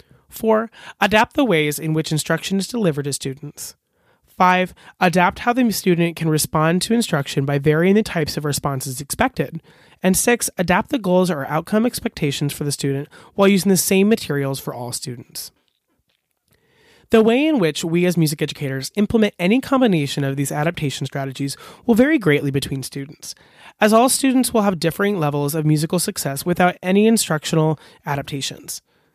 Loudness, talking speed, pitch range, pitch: -19 LUFS, 165 wpm, 145-205 Hz, 165 Hz